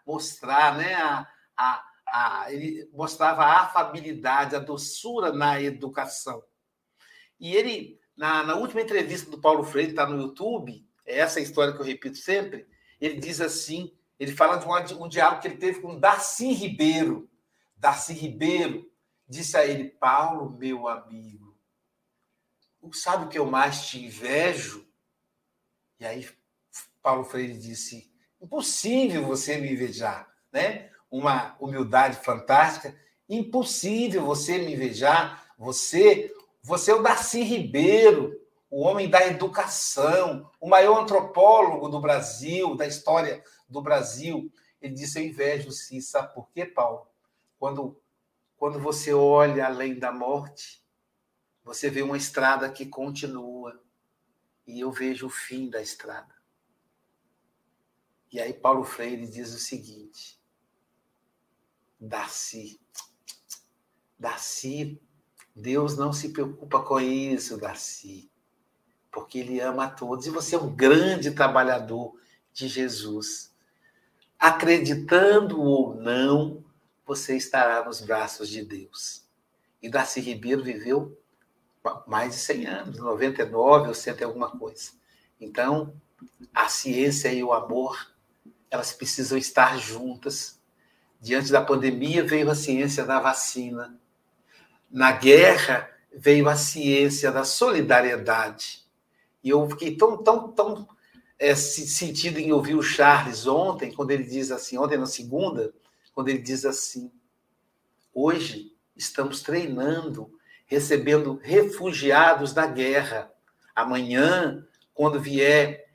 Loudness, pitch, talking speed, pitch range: -24 LUFS, 145 Hz, 125 wpm, 130-165 Hz